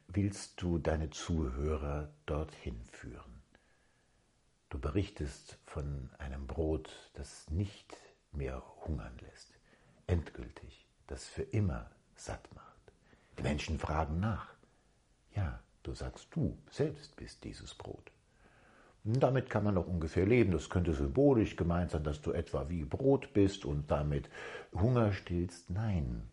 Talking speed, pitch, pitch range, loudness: 130 wpm, 85 Hz, 75-100 Hz, -36 LUFS